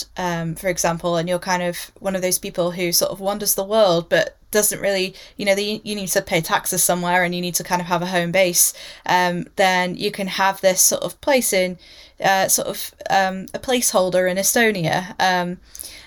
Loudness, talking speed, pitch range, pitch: -19 LUFS, 215 wpm, 180-200 Hz, 185 Hz